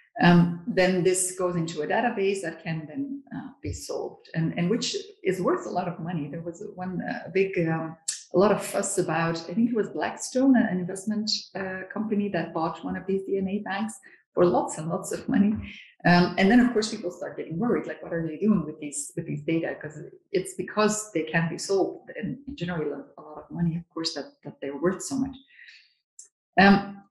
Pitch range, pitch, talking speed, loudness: 170-220 Hz, 185 Hz, 210 wpm, -26 LUFS